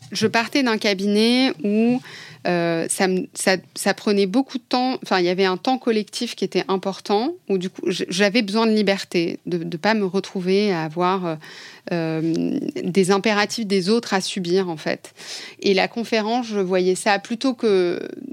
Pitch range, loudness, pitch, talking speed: 185-225 Hz, -21 LUFS, 200 Hz, 180 wpm